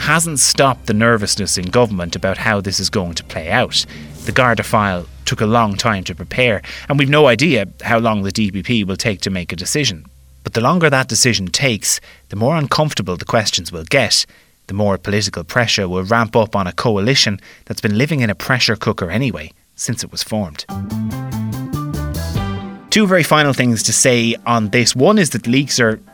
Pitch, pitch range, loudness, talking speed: 110 Hz, 95-125 Hz, -16 LUFS, 195 wpm